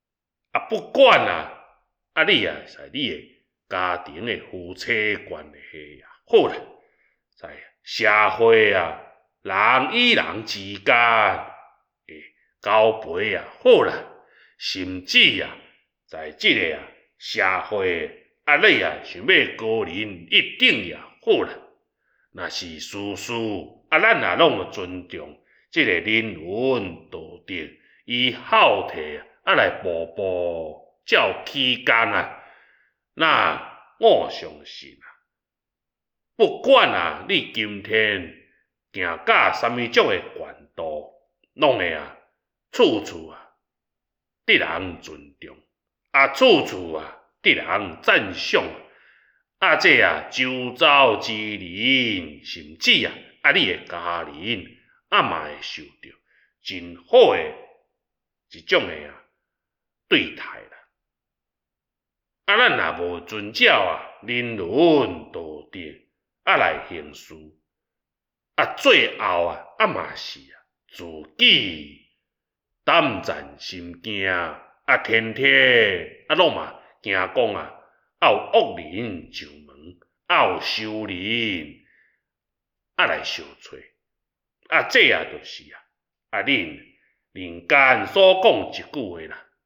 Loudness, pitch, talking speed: -19 LUFS, 110 Hz, 150 characters per minute